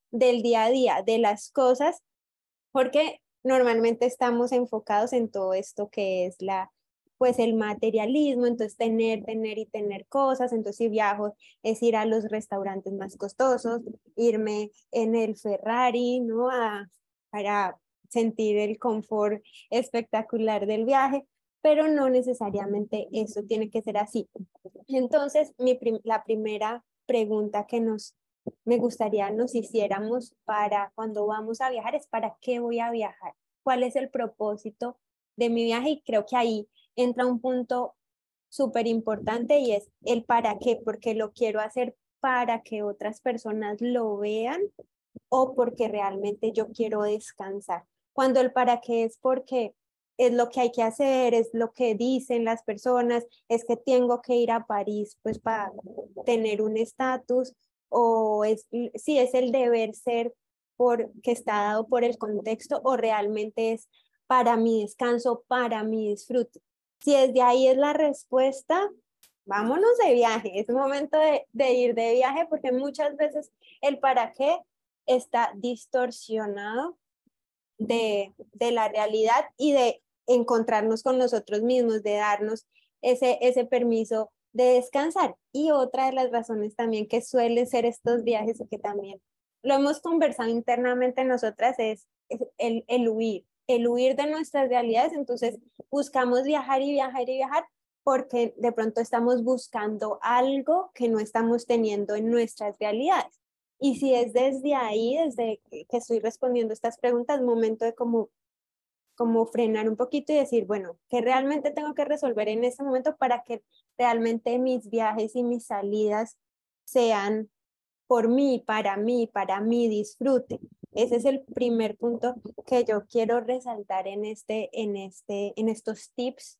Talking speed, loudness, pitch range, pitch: 150 wpm, -26 LUFS, 220-255 Hz, 235 Hz